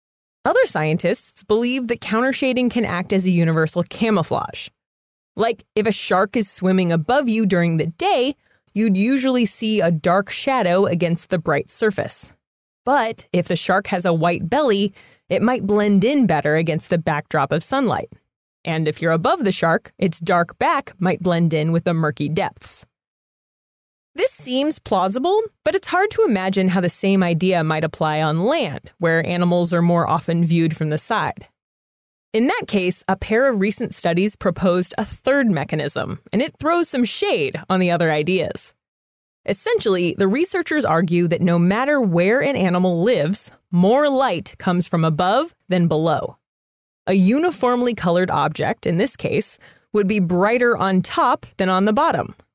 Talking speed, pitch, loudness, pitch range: 165 wpm, 185 Hz, -19 LUFS, 170-235 Hz